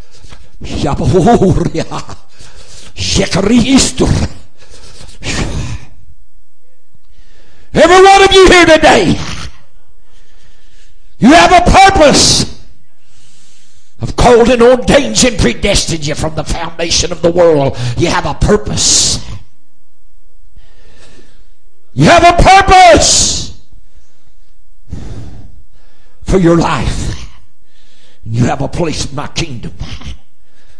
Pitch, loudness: 175 Hz, -8 LUFS